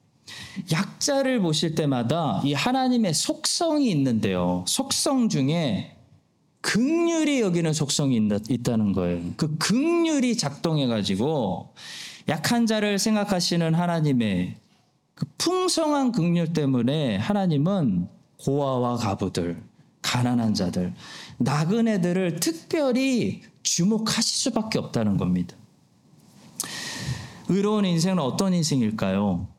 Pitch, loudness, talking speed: 170 Hz, -24 LUFS, 245 characters per minute